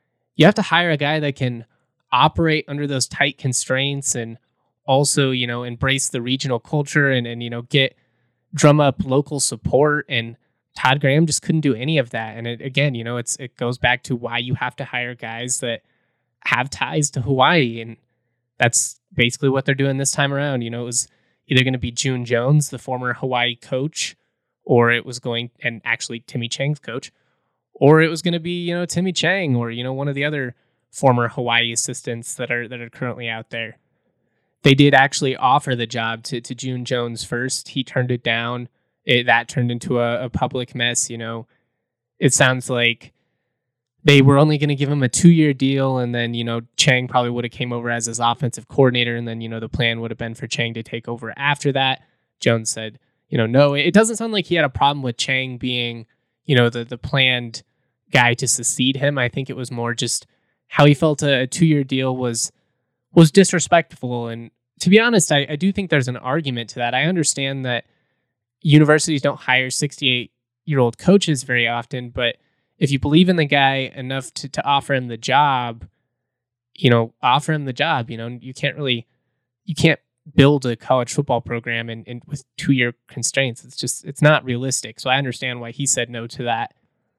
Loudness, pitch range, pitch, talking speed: -19 LUFS, 120-140 Hz, 130 Hz, 210 wpm